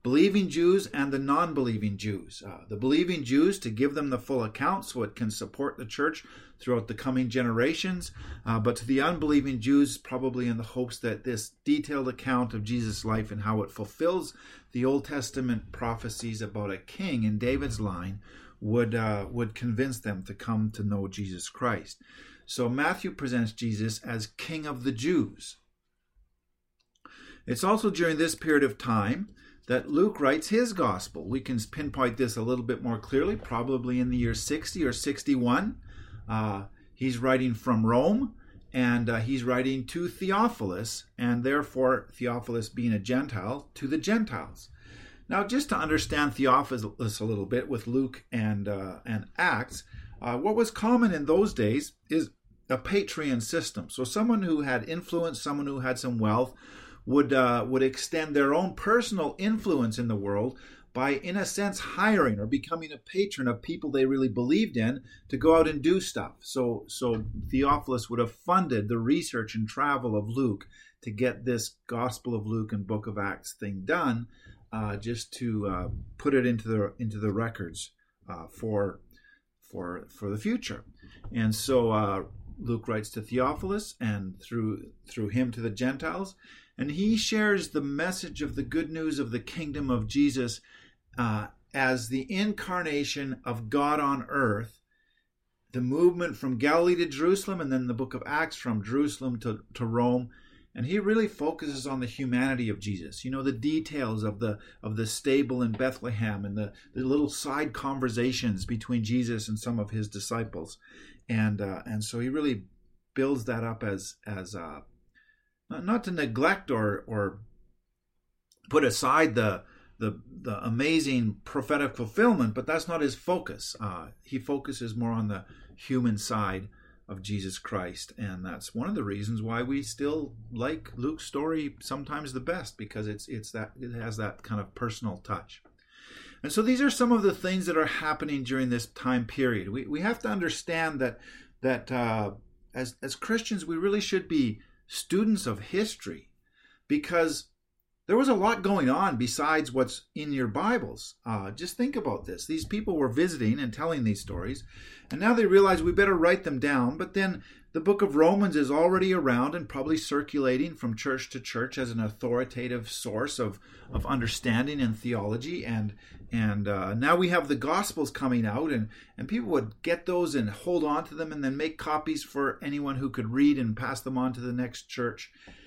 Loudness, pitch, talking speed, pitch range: -29 LUFS, 125 Hz, 175 wpm, 110-150 Hz